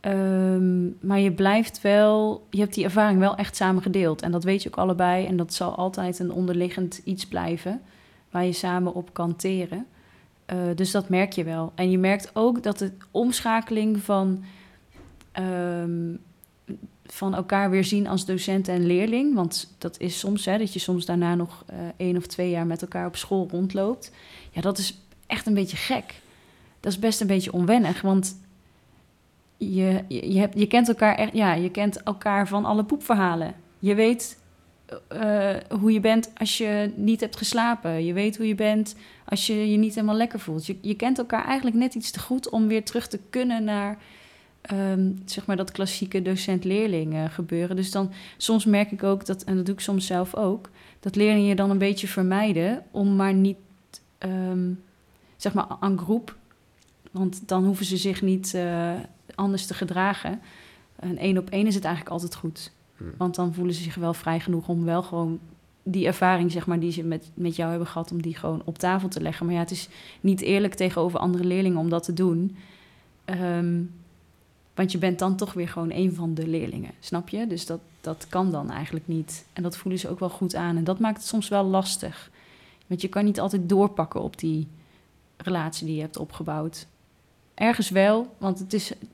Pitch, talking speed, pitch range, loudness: 190 Hz, 195 wpm, 175-205 Hz, -25 LUFS